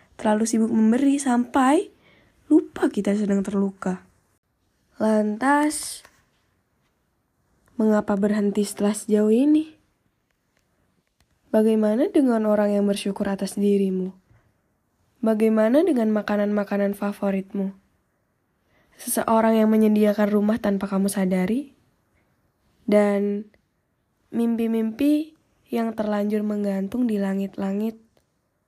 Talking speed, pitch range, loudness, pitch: 80 wpm, 200-230 Hz, -22 LUFS, 210 Hz